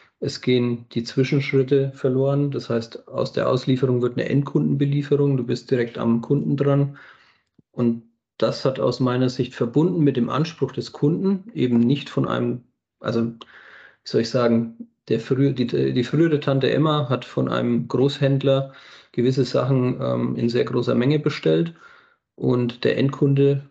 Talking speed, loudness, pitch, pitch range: 155 wpm, -22 LUFS, 130 Hz, 120-140 Hz